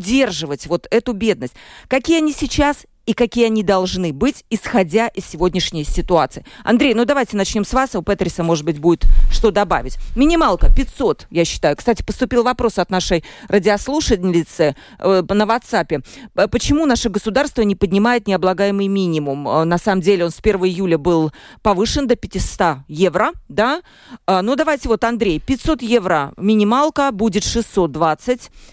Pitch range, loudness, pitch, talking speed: 175-240 Hz, -17 LUFS, 205 Hz, 150 wpm